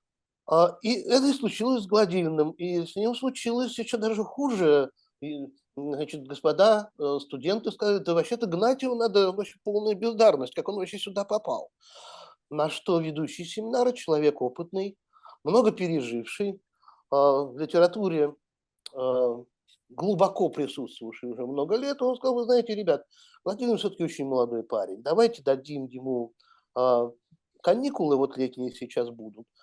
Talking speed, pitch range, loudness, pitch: 130 wpm, 140-220 Hz, -27 LUFS, 175 Hz